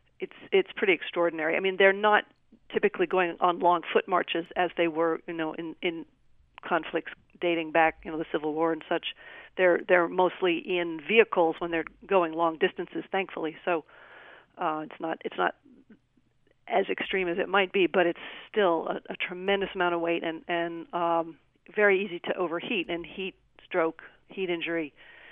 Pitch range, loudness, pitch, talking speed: 165-195 Hz, -28 LUFS, 175 Hz, 180 wpm